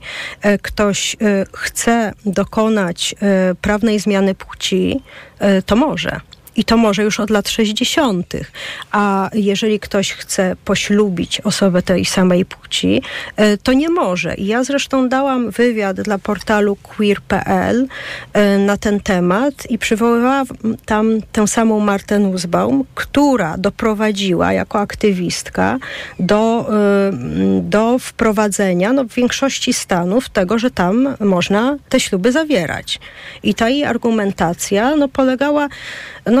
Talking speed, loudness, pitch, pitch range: 115 wpm, -16 LUFS, 210 Hz, 200-245 Hz